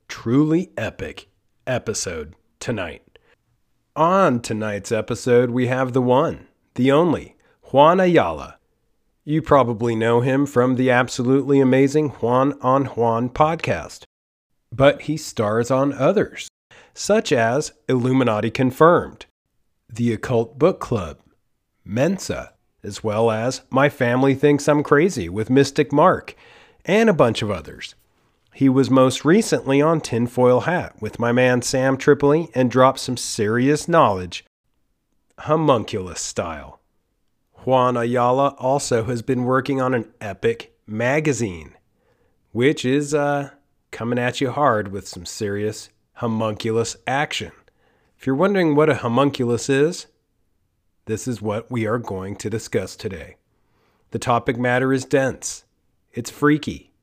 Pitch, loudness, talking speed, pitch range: 125 Hz, -19 LUFS, 125 wpm, 115-140 Hz